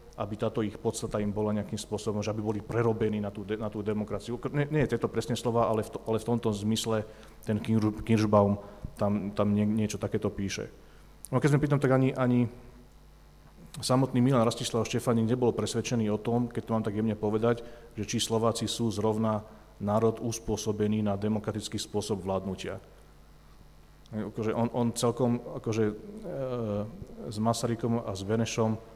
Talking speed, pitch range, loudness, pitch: 170 wpm, 105-120 Hz, -30 LUFS, 110 Hz